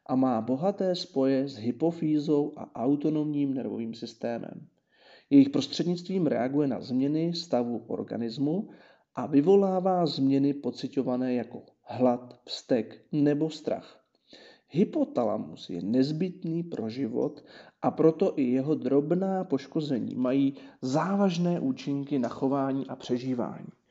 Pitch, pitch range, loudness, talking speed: 140 Hz, 130-165 Hz, -28 LUFS, 110 wpm